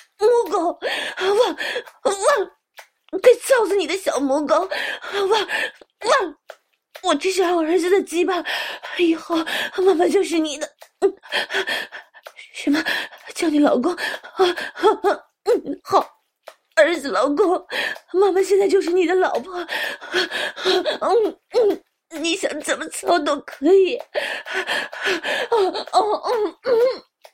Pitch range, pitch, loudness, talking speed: 335-425 Hz, 370 Hz, -20 LUFS, 160 characters per minute